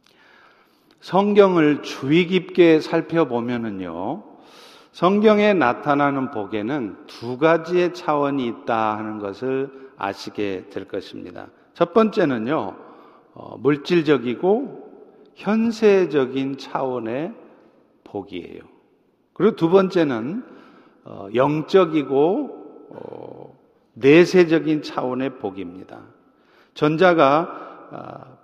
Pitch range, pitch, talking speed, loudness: 130-195 Hz, 160 Hz, 195 characters per minute, -20 LUFS